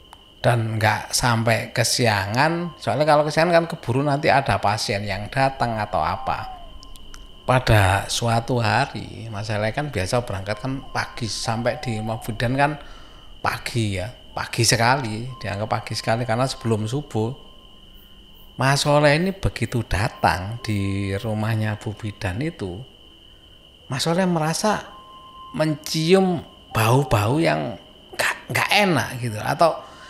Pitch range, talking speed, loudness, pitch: 105-140 Hz, 120 wpm, -22 LUFS, 115 Hz